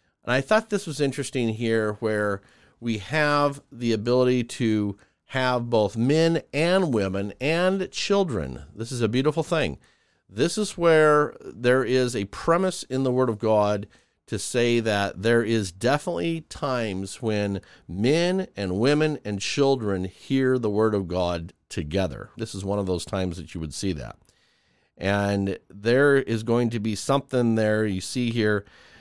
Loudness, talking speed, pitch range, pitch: -24 LUFS, 160 wpm, 100-140 Hz, 115 Hz